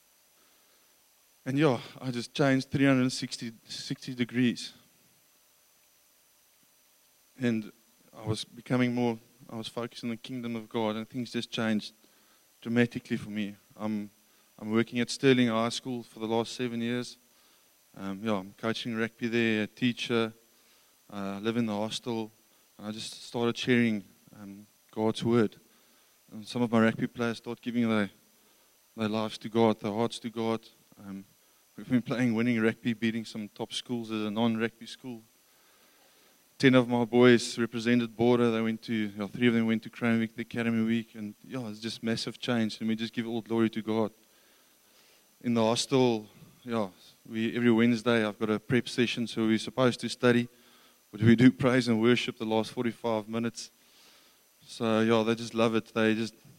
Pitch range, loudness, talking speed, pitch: 110-120 Hz, -29 LUFS, 180 wpm, 115 Hz